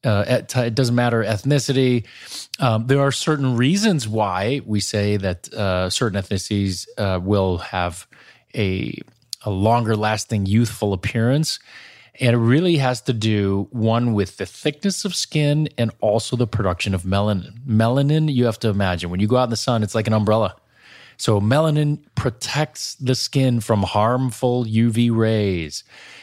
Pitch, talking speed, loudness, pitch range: 115 Hz, 160 wpm, -20 LUFS, 105-130 Hz